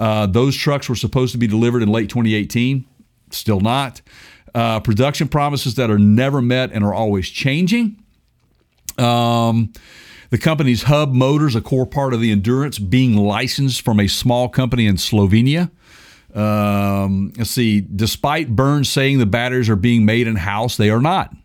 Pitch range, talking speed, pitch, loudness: 110-135 Hz, 165 wpm, 120 Hz, -17 LUFS